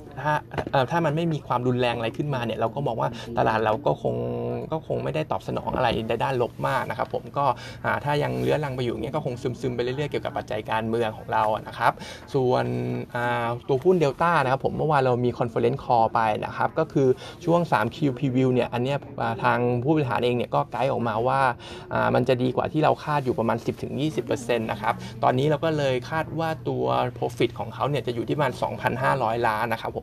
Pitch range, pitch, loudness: 115-140 Hz, 125 Hz, -25 LUFS